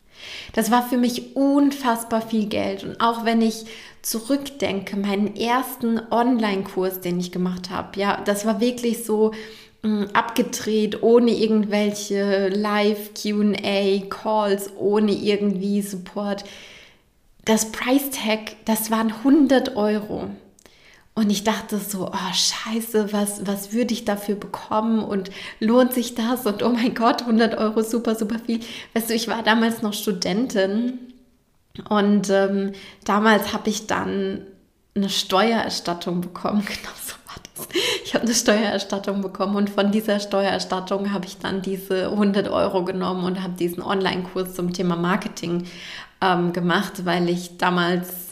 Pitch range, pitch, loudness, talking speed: 195-225 Hz, 210 Hz, -22 LUFS, 140 wpm